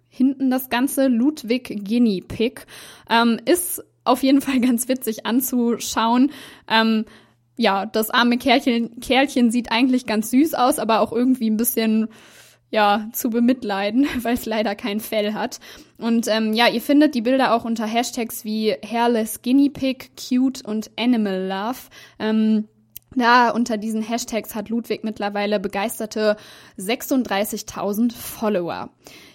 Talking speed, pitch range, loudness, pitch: 140 wpm, 215-250 Hz, -20 LUFS, 230 Hz